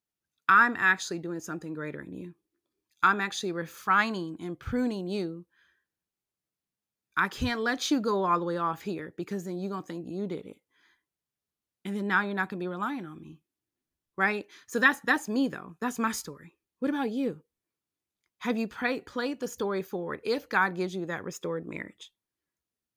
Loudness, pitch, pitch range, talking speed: -29 LUFS, 195 Hz, 175-240 Hz, 180 wpm